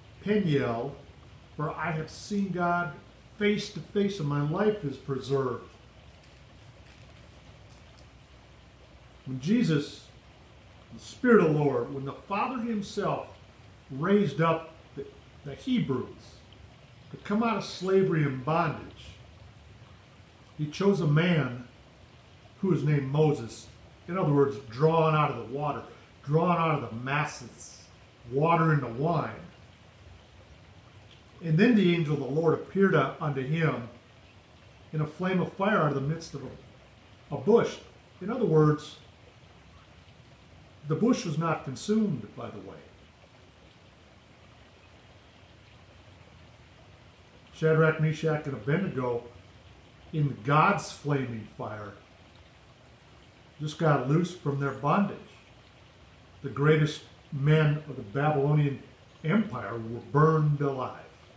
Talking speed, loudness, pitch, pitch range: 115 wpm, -28 LUFS, 140 Hz, 110-160 Hz